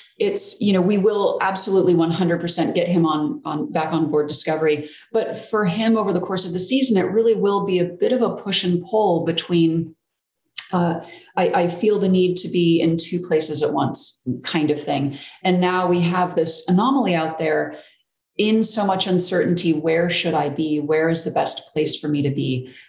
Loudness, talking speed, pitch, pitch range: -19 LUFS, 205 wpm, 175 Hz, 160-195 Hz